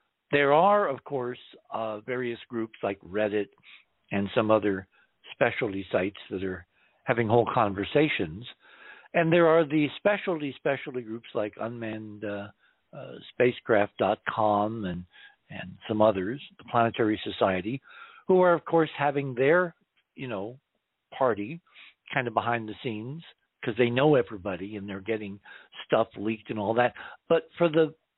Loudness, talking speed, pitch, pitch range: -27 LUFS, 145 wpm, 120 Hz, 105-145 Hz